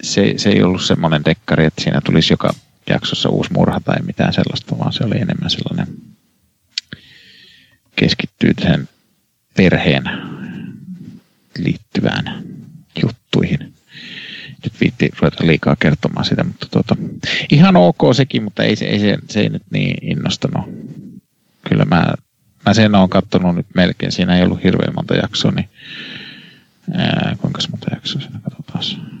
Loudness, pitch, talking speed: -16 LUFS, 105 Hz, 140 wpm